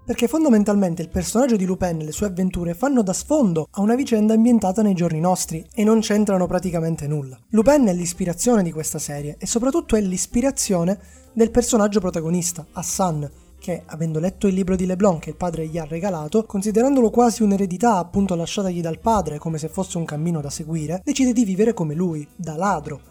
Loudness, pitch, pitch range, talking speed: -21 LUFS, 185 Hz, 165-220 Hz, 190 wpm